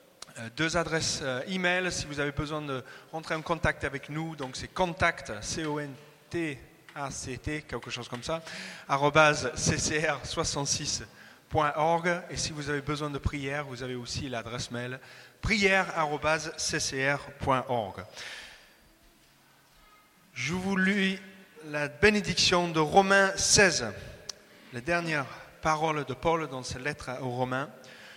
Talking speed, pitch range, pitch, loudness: 115 wpm, 130-165 Hz, 150 Hz, -29 LUFS